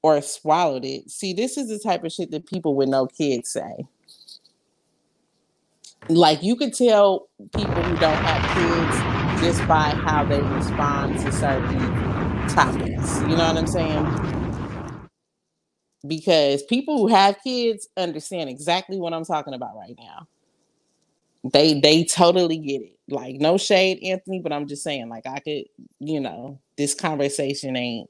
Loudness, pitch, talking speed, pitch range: -21 LUFS, 160 Hz, 155 wpm, 140-190 Hz